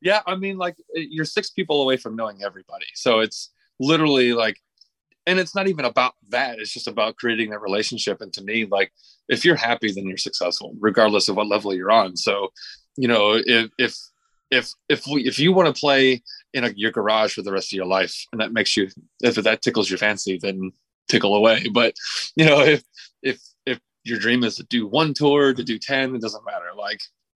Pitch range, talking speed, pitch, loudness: 105-150 Hz, 215 wpm, 120 Hz, -21 LUFS